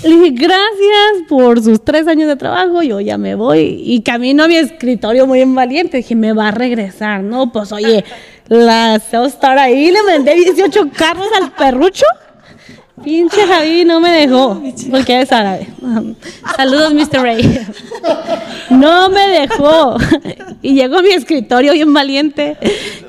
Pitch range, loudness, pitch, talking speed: 240-330 Hz, -10 LUFS, 275 Hz, 155 wpm